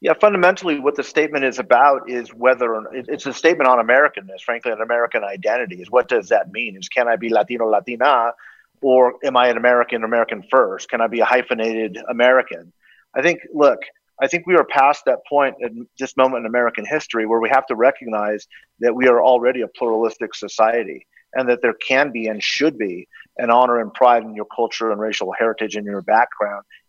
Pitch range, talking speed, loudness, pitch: 115-130 Hz, 205 wpm, -18 LUFS, 120 Hz